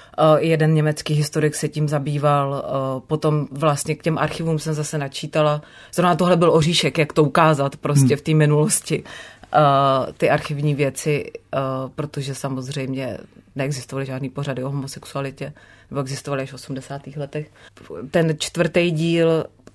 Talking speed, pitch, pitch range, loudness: 135 wpm, 150 Hz, 140-155 Hz, -20 LUFS